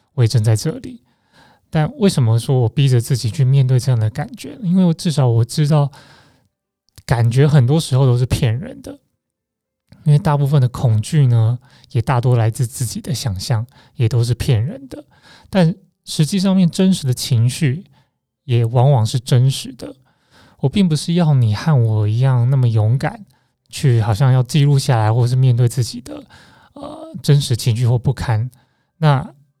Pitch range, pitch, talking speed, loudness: 120-150 Hz, 130 Hz, 245 characters per minute, -16 LUFS